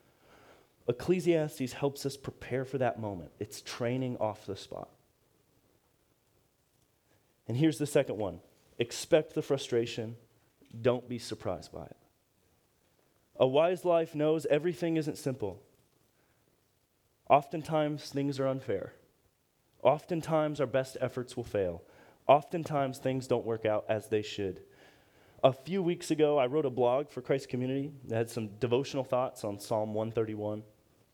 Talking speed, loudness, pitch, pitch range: 135 wpm, -32 LUFS, 130 Hz, 115-150 Hz